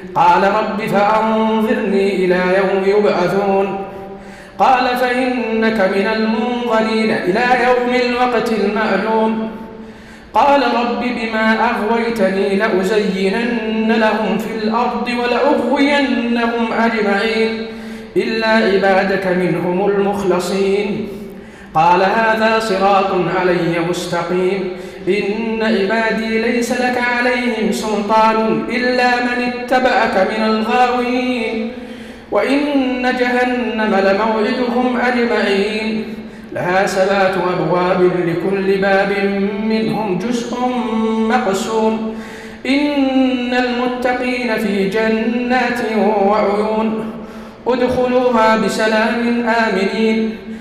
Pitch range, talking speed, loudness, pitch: 195-240 Hz, 75 wpm, -15 LUFS, 220 Hz